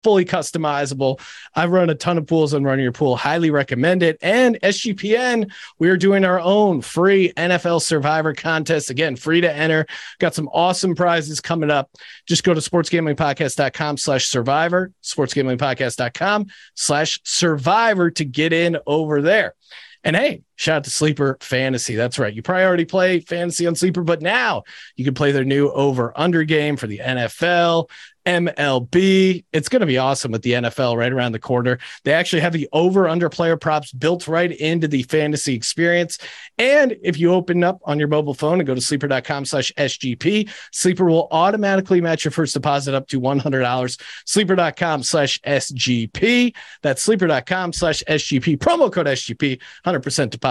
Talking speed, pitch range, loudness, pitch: 165 wpm, 140-175 Hz, -18 LUFS, 155 Hz